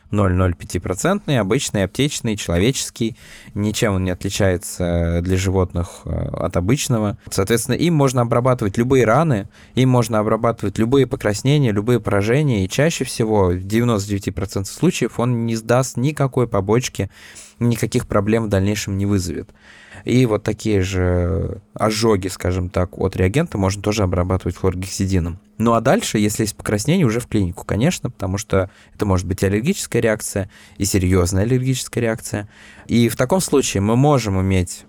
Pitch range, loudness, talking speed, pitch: 95-120 Hz, -19 LUFS, 145 wpm, 105 Hz